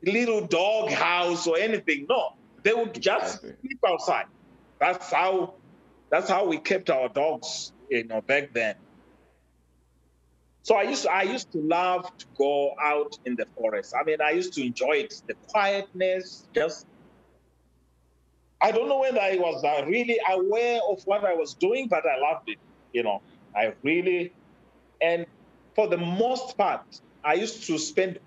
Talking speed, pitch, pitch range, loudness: 165 wpm, 185 Hz, 145-225 Hz, -26 LUFS